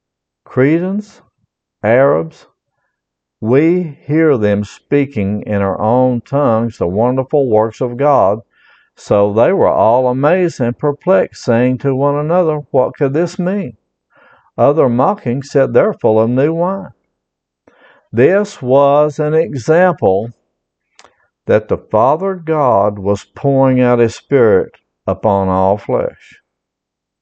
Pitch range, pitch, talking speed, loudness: 110-155 Hz, 135 Hz, 120 wpm, -13 LUFS